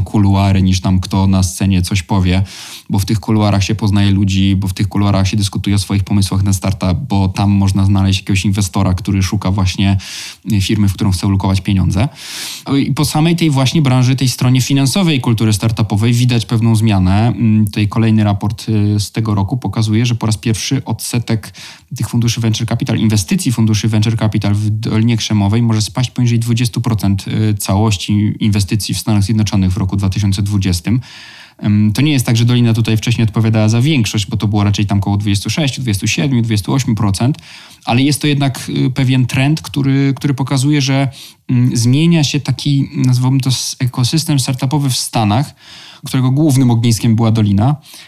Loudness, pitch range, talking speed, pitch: -14 LUFS, 100-125 Hz, 165 wpm, 110 Hz